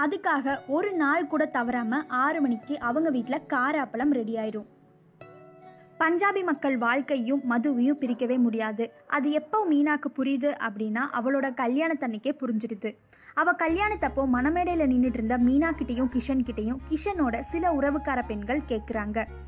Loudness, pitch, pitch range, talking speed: -27 LUFS, 270 Hz, 245-300 Hz, 120 wpm